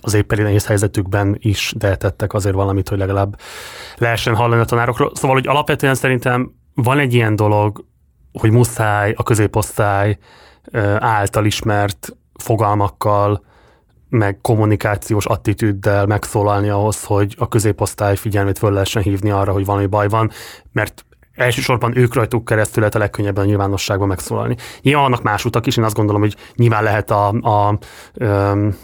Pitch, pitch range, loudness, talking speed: 105 Hz, 100-115 Hz, -16 LUFS, 150 wpm